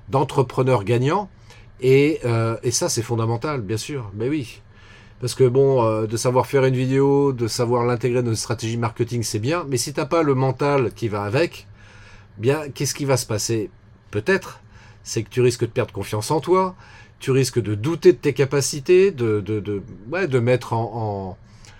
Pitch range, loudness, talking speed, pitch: 110-135 Hz, -21 LUFS, 200 wpm, 120 Hz